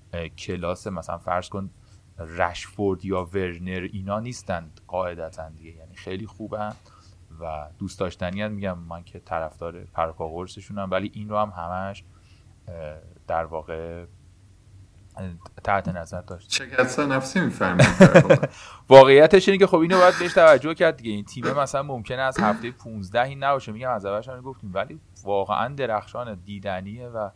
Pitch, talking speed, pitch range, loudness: 100 Hz, 140 wpm, 90-110 Hz, -21 LUFS